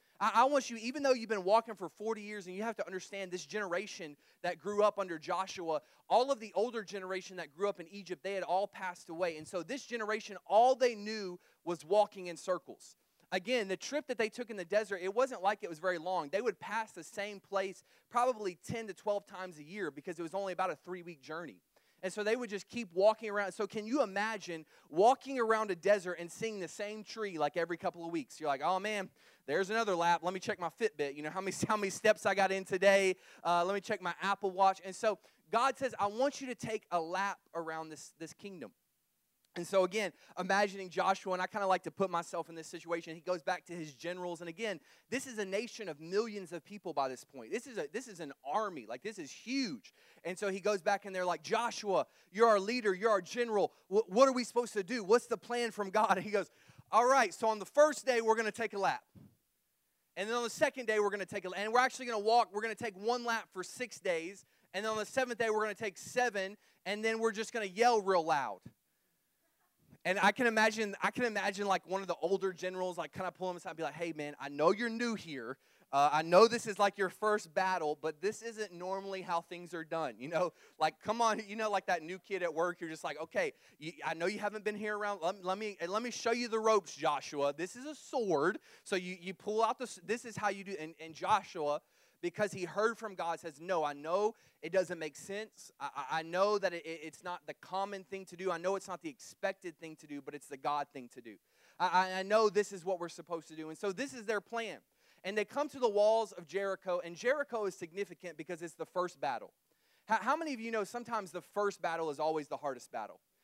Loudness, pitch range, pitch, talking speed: -35 LUFS, 175-220 Hz, 195 Hz, 250 wpm